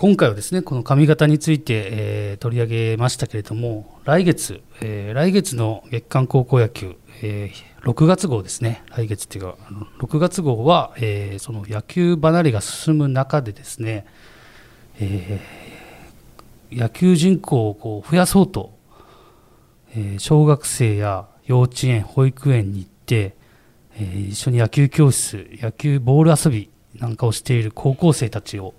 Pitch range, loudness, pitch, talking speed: 105-145 Hz, -19 LUFS, 115 Hz, 280 characters per minute